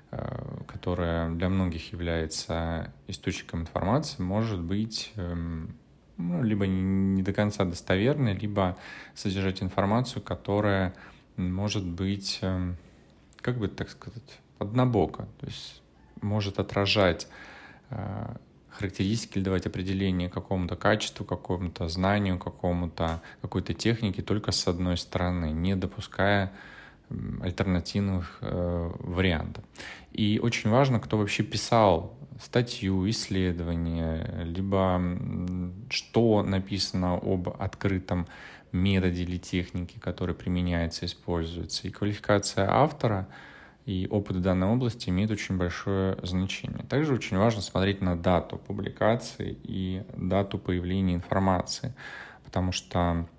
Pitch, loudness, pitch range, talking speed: 95 Hz, -29 LUFS, 90-105 Hz, 105 wpm